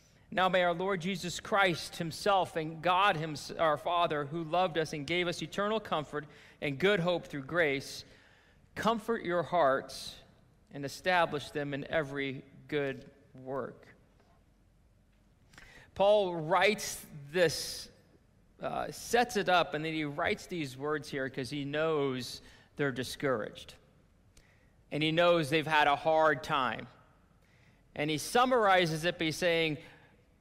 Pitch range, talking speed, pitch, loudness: 145-180 Hz, 135 wpm, 160 Hz, -31 LUFS